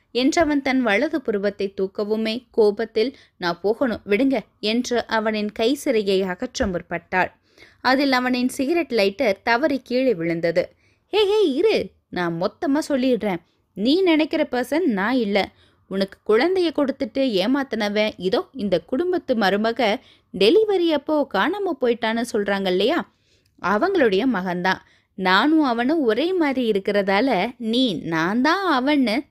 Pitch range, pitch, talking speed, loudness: 200-290 Hz, 245 Hz, 120 wpm, -21 LUFS